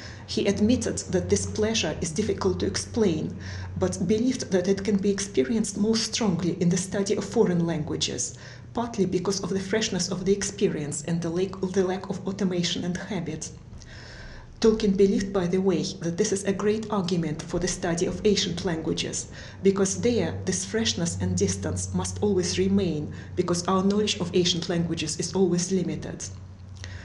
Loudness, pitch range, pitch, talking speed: -26 LUFS, 155-200 Hz, 185 Hz, 165 wpm